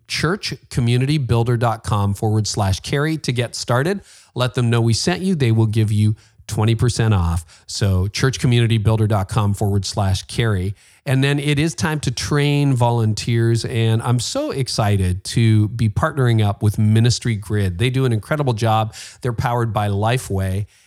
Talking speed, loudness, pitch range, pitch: 155 wpm, -19 LUFS, 105-125 Hz, 115 Hz